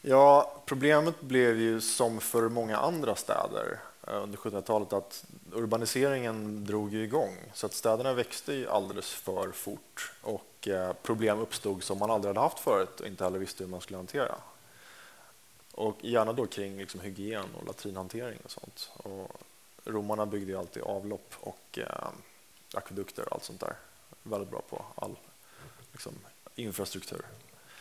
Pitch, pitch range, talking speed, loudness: 110 Hz, 100-115 Hz, 150 wpm, -32 LUFS